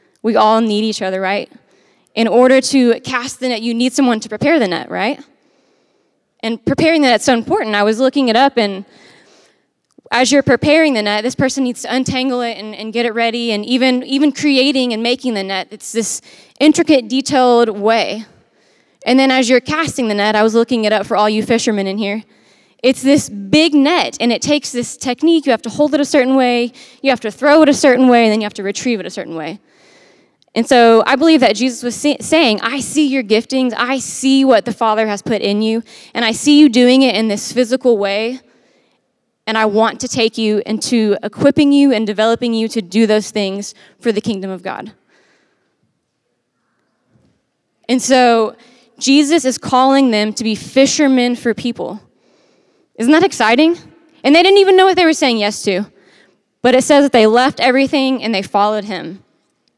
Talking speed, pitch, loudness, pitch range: 205 wpm, 240 Hz, -13 LUFS, 220-270 Hz